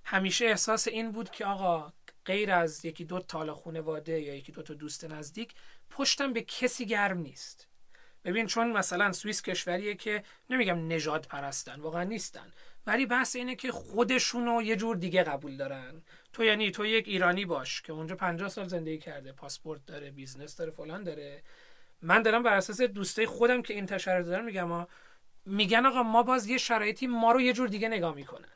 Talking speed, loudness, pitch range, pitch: 185 wpm, -30 LUFS, 165-230 Hz, 195 Hz